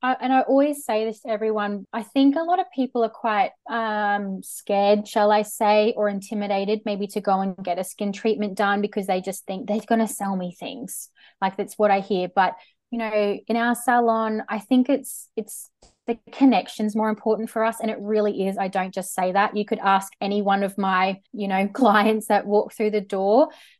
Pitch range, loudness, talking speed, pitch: 200-225 Hz, -23 LUFS, 220 wpm, 210 Hz